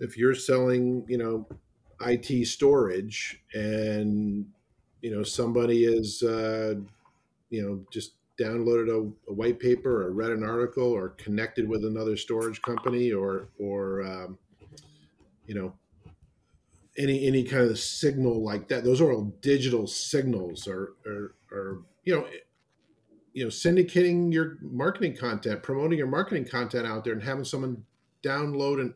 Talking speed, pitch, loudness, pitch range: 145 wpm, 115 Hz, -28 LUFS, 105-125 Hz